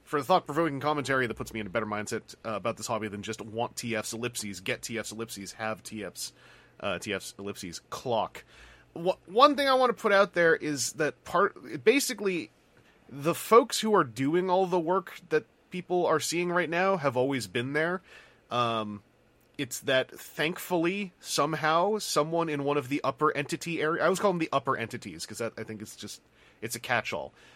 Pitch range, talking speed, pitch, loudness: 115-175 Hz, 190 wpm, 145 Hz, -29 LUFS